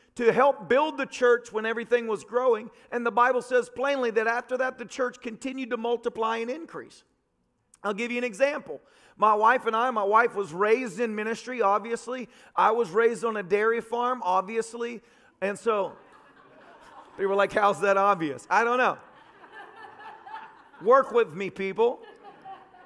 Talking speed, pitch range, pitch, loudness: 165 wpm, 220-255 Hz, 235 Hz, -26 LUFS